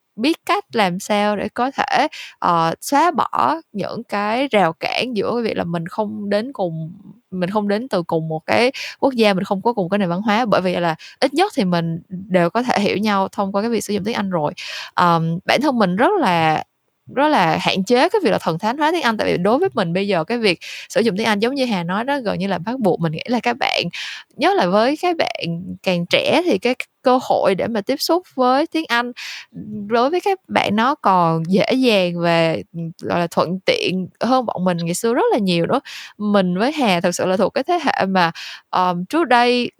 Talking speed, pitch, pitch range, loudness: 240 wpm, 205 Hz, 180-245 Hz, -18 LUFS